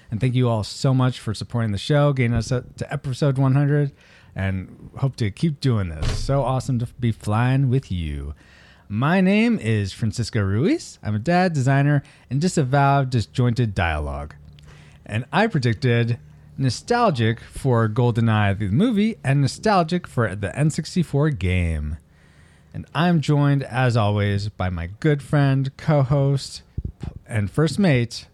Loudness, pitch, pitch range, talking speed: -21 LUFS, 125 Hz, 105-145 Hz, 145 wpm